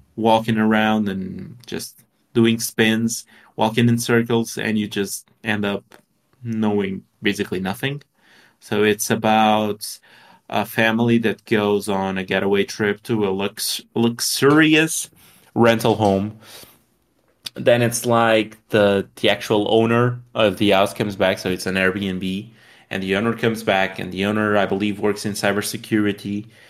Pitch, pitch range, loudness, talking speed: 105 Hz, 100-115 Hz, -20 LUFS, 140 wpm